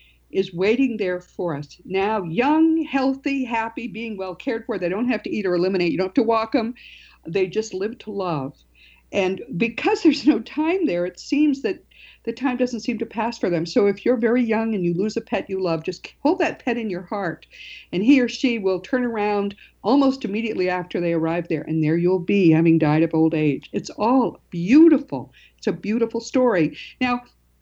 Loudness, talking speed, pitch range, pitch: -22 LUFS, 210 wpm, 180-250 Hz, 215 Hz